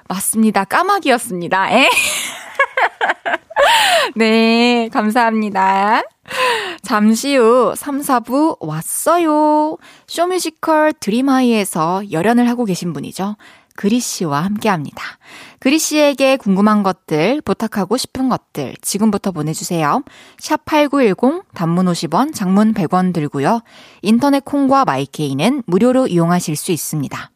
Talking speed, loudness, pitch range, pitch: 245 characters per minute, -15 LUFS, 190-280 Hz, 225 Hz